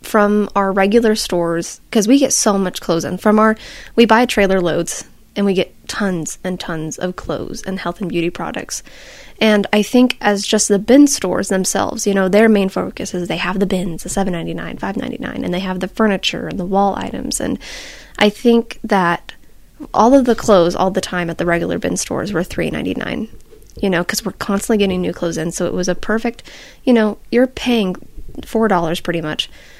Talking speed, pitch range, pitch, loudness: 200 wpm, 180-220 Hz, 195 Hz, -16 LUFS